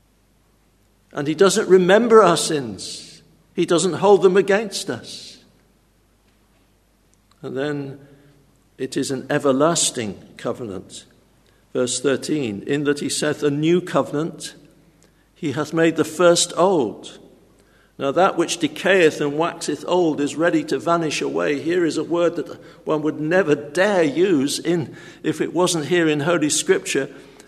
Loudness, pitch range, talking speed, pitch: -19 LUFS, 140-175 Hz, 140 wpm, 155 Hz